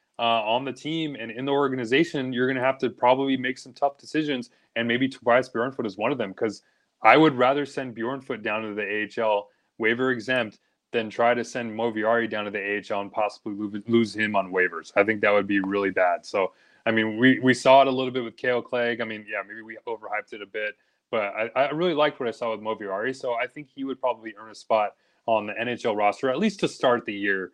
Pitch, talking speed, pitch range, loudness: 115 Hz, 245 wpm, 110-130 Hz, -25 LUFS